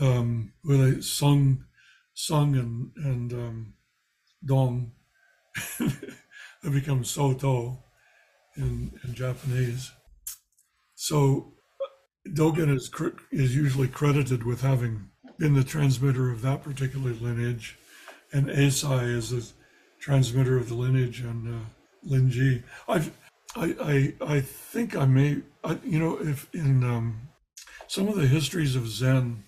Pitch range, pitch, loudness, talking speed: 125-145 Hz, 130 Hz, -27 LUFS, 120 wpm